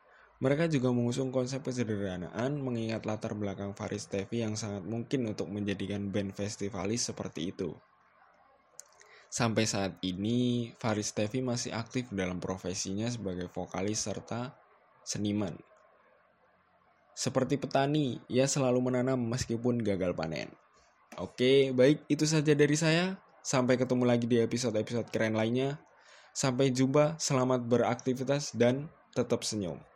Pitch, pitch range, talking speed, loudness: 120 Hz, 105-130 Hz, 120 wpm, -31 LUFS